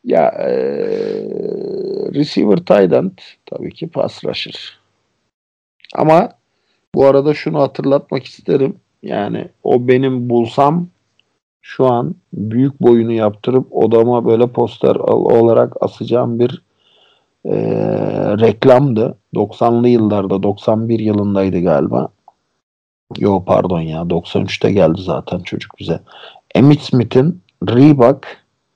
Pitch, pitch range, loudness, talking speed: 125 Hz, 115-145 Hz, -14 LUFS, 95 wpm